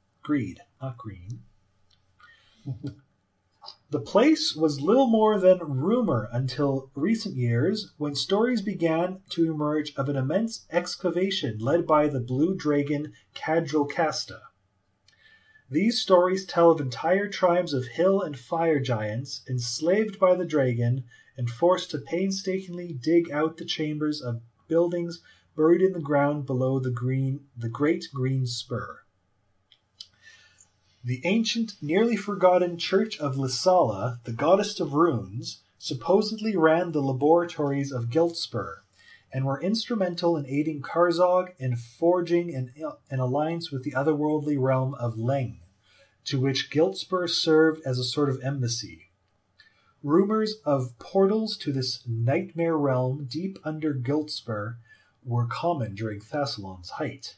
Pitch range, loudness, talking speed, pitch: 125-175 Hz, -26 LUFS, 130 wpm, 150 Hz